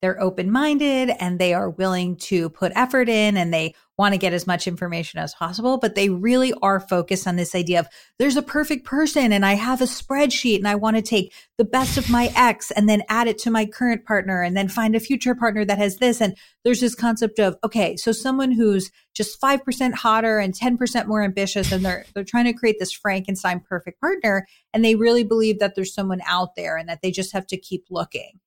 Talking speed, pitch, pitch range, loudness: 230 wpm, 210 Hz, 185-240 Hz, -21 LUFS